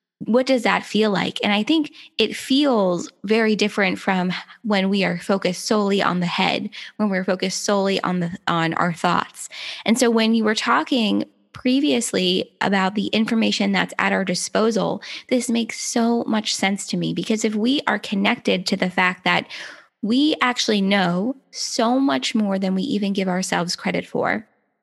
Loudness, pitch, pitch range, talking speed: -20 LUFS, 210 Hz, 190-235 Hz, 175 wpm